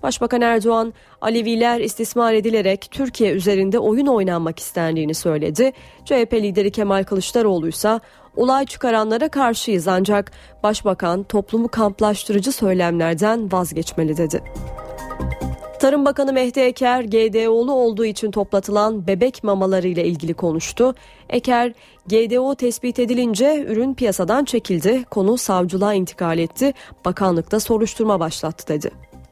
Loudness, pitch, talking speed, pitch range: -19 LUFS, 215 Hz, 110 wpm, 185-235 Hz